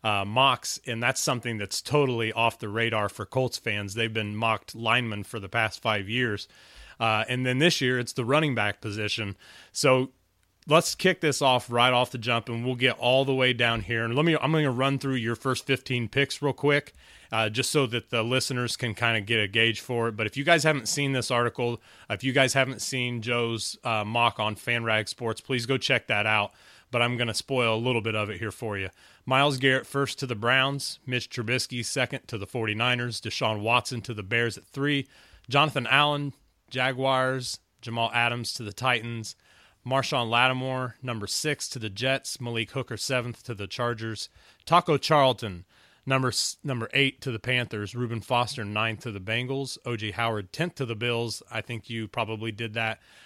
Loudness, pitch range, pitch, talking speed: -26 LUFS, 110-130 Hz, 120 Hz, 200 wpm